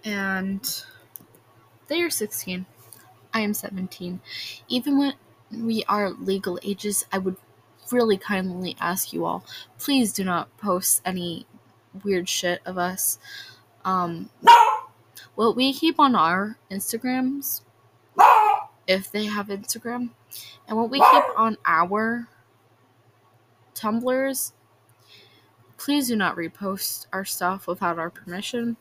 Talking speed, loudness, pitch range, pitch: 115 wpm, -23 LUFS, 175-230 Hz, 195 Hz